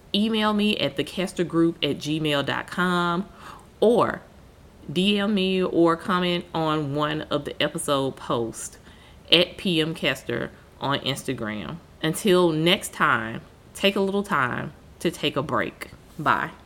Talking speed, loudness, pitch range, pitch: 120 wpm, -24 LUFS, 145-185 Hz, 165 Hz